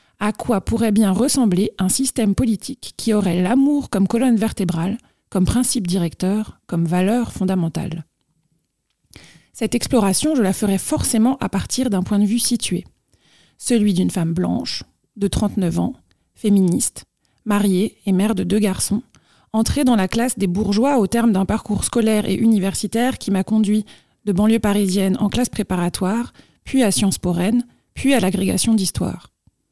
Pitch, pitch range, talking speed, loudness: 210 Hz, 190-230 Hz, 155 wpm, -19 LUFS